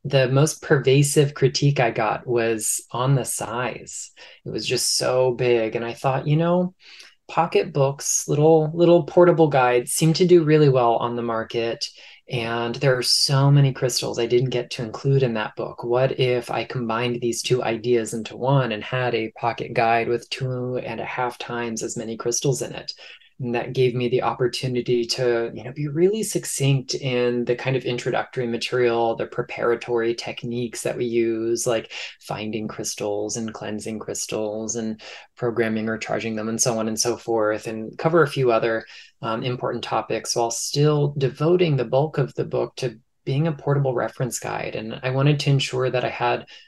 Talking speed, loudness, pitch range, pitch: 185 wpm, -22 LUFS, 115-135 Hz, 125 Hz